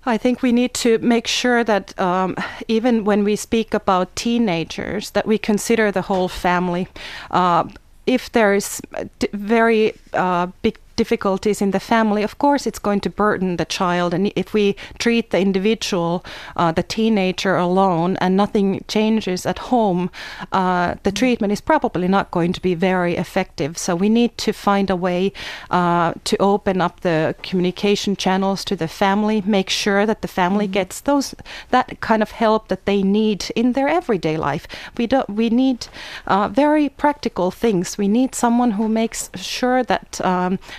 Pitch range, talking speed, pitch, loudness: 185-230 Hz, 170 wpm, 205 Hz, -19 LUFS